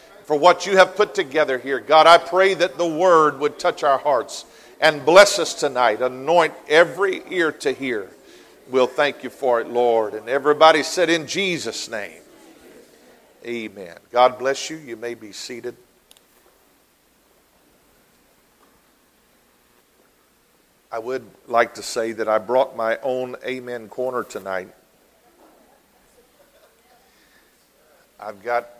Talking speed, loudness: 125 wpm, -19 LUFS